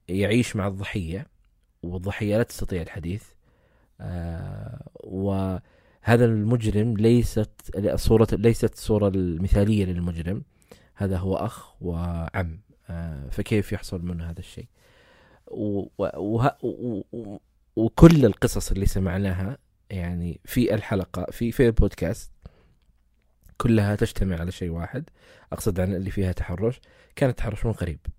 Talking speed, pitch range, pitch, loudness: 100 wpm, 90-110 Hz, 100 Hz, -25 LUFS